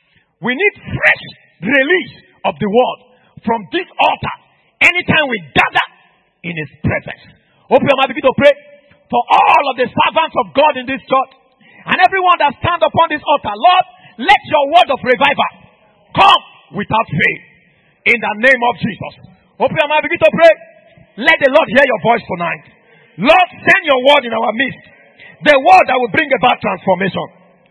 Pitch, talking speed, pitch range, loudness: 265 Hz, 170 wpm, 215-315 Hz, -12 LUFS